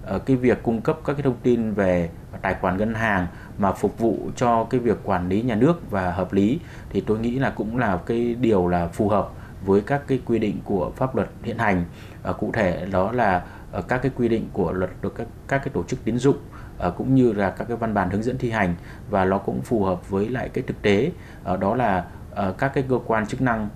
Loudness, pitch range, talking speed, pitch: -23 LUFS, 95-125 Hz, 240 wpm, 110 Hz